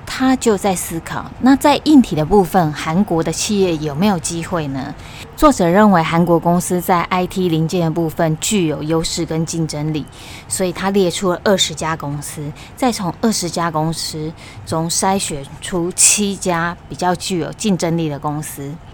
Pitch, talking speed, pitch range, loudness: 170 Hz, 255 characters per minute, 155-190 Hz, -16 LUFS